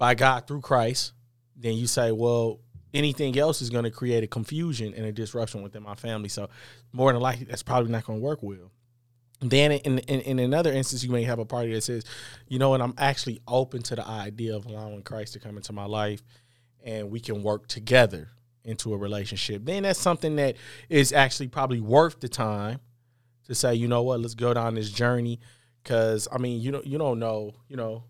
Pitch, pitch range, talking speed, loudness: 120 Hz, 110-130 Hz, 215 wpm, -26 LUFS